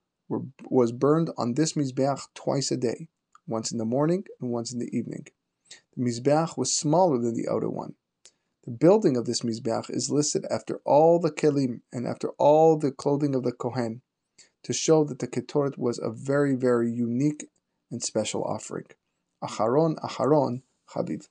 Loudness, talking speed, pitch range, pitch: -26 LUFS, 170 wpm, 120-150 Hz, 130 Hz